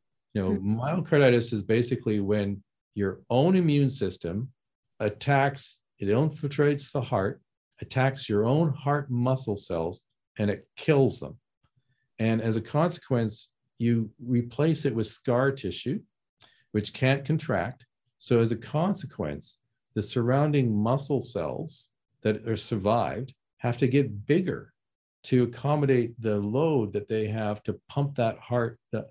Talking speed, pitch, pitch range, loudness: 135 wpm, 120 Hz, 110-140 Hz, -27 LUFS